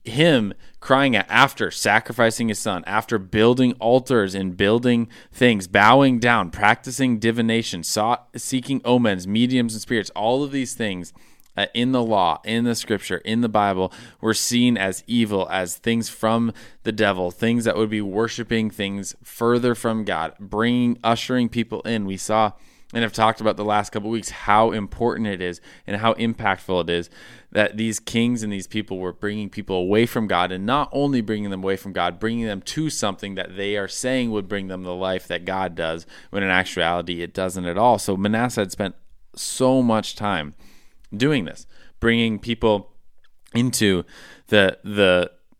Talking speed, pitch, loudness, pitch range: 180 wpm, 110 Hz, -21 LUFS, 95-115 Hz